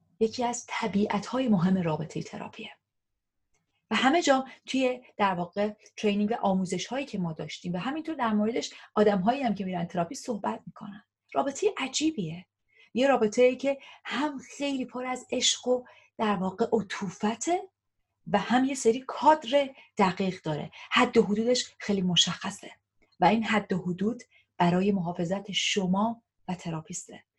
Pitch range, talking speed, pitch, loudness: 185-250 Hz, 150 wpm, 215 Hz, -28 LUFS